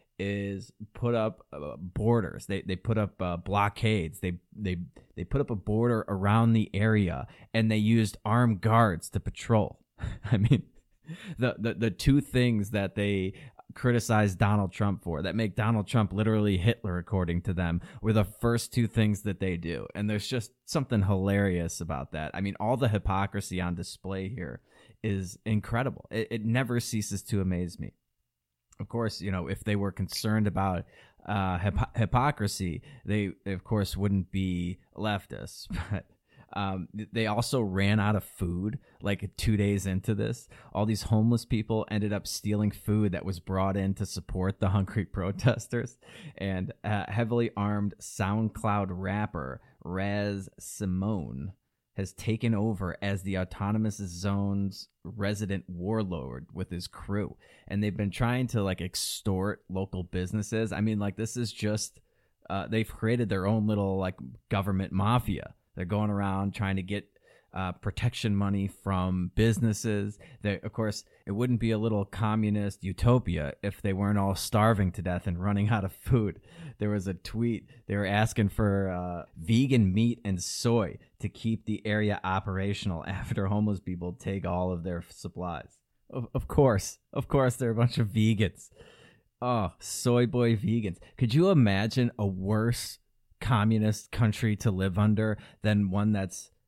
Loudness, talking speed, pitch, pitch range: -29 LUFS, 160 wpm, 105 Hz, 95-110 Hz